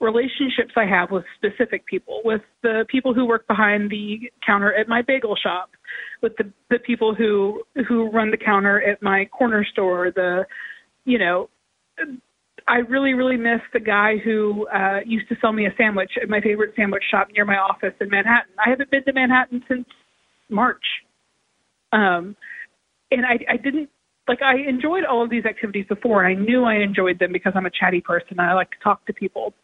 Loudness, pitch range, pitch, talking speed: -20 LUFS, 200-245 Hz, 220 Hz, 195 wpm